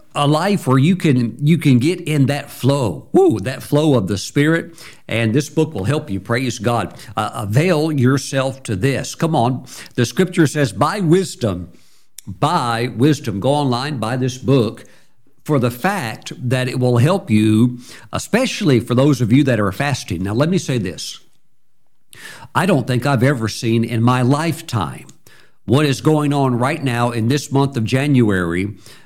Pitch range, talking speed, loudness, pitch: 115-150 Hz, 175 wpm, -17 LUFS, 130 Hz